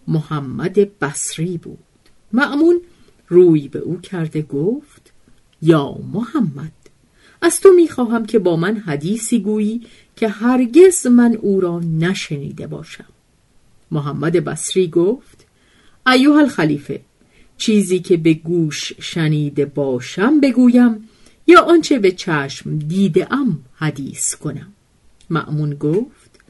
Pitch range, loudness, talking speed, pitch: 155-235 Hz, -16 LUFS, 110 wpm, 185 Hz